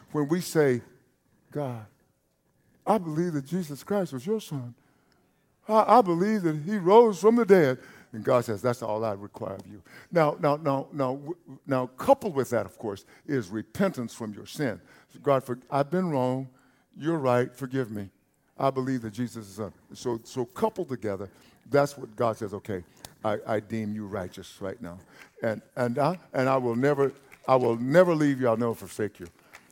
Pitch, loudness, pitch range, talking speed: 130 Hz, -27 LUFS, 115-155 Hz, 185 wpm